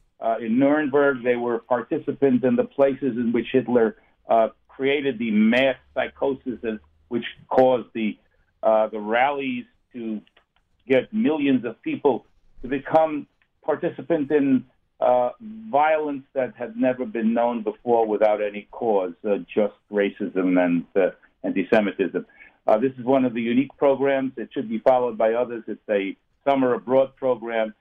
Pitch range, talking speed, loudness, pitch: 115-140 Hz, 150 wpm, -23 LUFS, 125 Hz